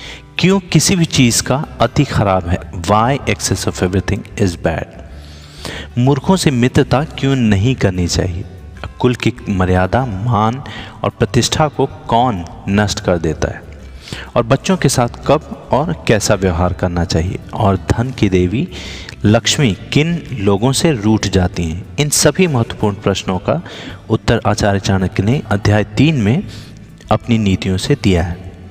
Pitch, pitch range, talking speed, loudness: 105 Hz, 95-125 Hz, 150 wpm, -15 LUFS